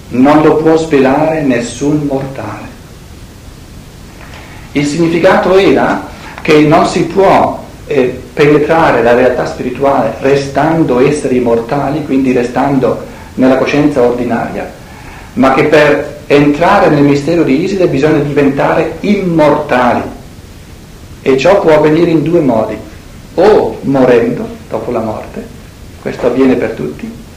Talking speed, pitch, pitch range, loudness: 115 wpm, 145 Hz, 125-155 Hz, -10 LUFS